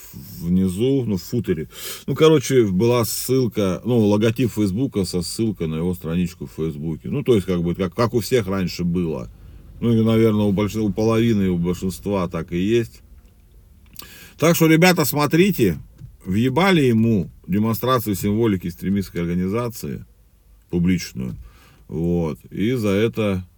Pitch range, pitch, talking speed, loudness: 90-120 Hz, 105 Hz, 145 wpm, -20 LUFS